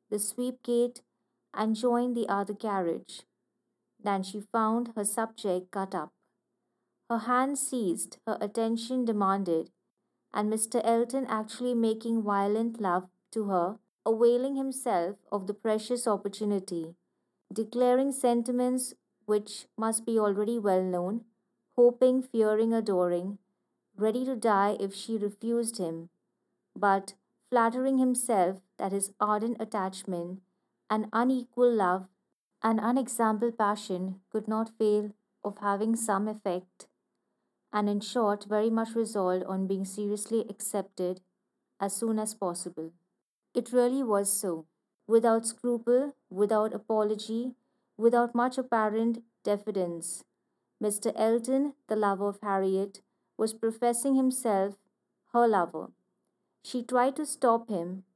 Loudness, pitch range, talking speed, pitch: -29 LUFS, 195-235 Hz, 120 wpm, 215 Hz